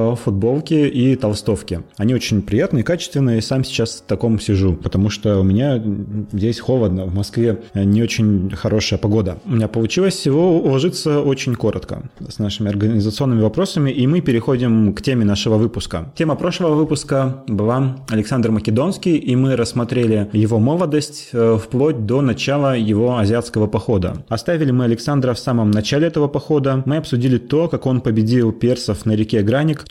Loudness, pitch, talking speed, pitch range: -17 LUFS, 115 Hz, 155 wpm, 105-135 Hz